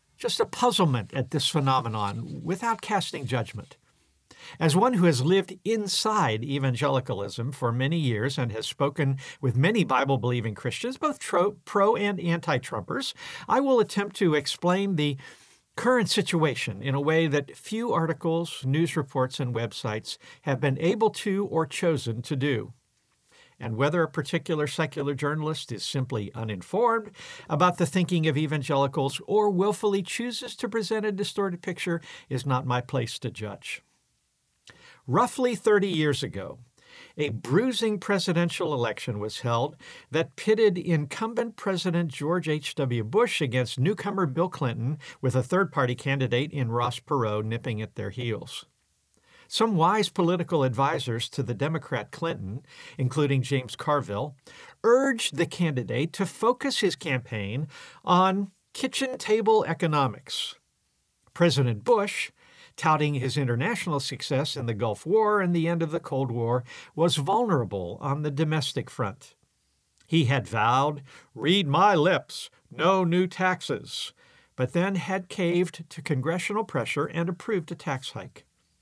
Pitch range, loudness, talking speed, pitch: 130-190 Hz, -26 LUFS, 140 wpm, 155 Hz